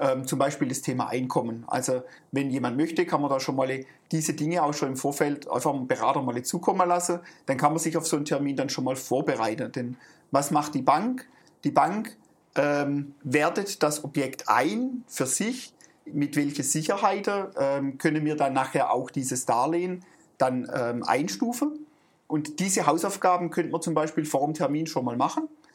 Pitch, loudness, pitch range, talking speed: 150 Hz, -27 LUFS, 135-180 Hz, 175 wpm